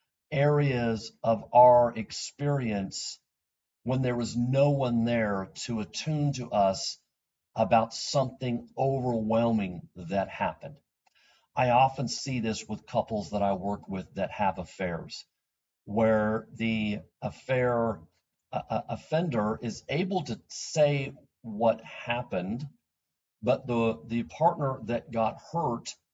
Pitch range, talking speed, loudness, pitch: 110-130 Hz, 115 wpm, -29 LUFS, 115 Hz